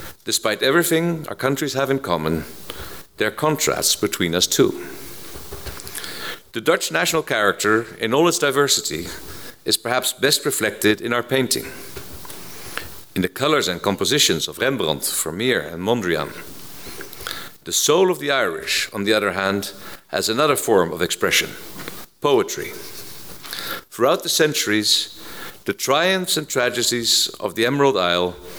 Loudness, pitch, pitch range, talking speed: -20 LUFS, 125 Hz, 100-150 Hz, 135 wpm